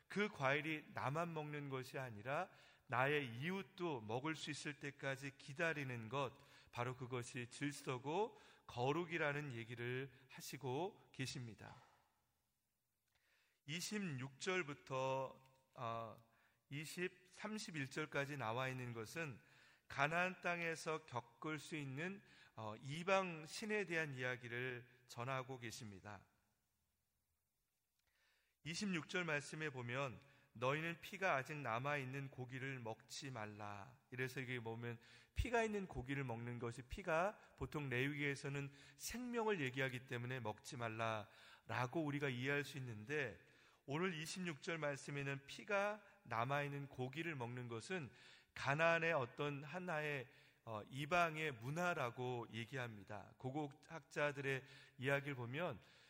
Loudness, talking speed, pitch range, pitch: -45 LUFS, 240 characters per minute, 125-155 Hz, 140 Hz